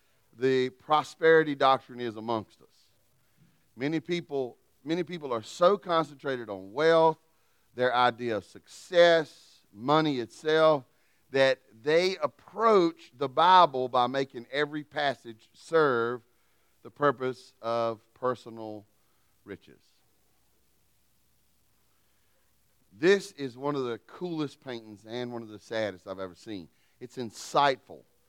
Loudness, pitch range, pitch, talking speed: -27 LUFS, 115-155 Hz, 130 Hz, 110 wpm